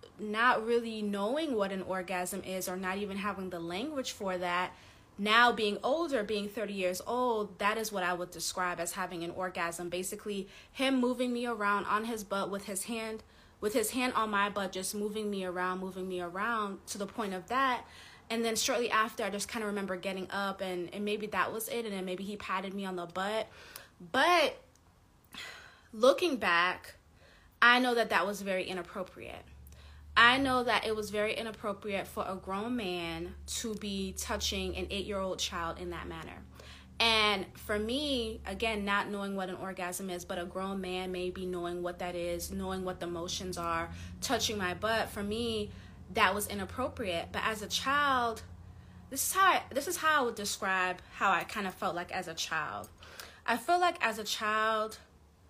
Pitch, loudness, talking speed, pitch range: 200 Hz, -32 LUFS, 195 wpm, 185-225 Hz